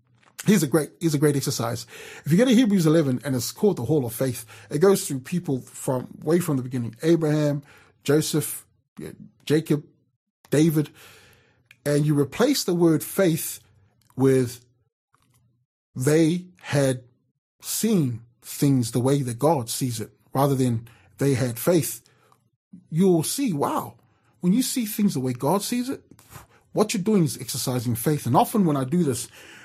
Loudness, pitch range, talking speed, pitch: -23 LUFS, 125-170 Hz, 160 wpm, 140 Hz